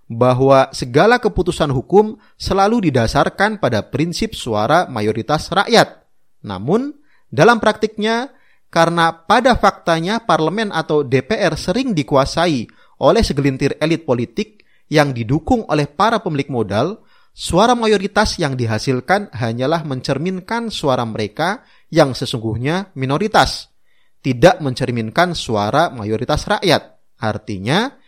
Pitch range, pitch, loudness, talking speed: 130-205 Hz, 160 Hz, -17 LUFS, 105 wpm